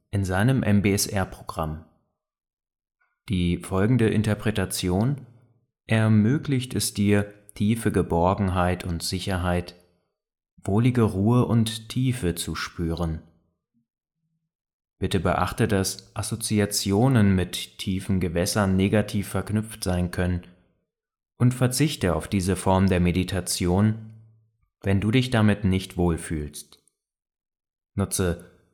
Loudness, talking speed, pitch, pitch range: -24 LUFS, 90 wpm, 100 Hz, 90-110 Hz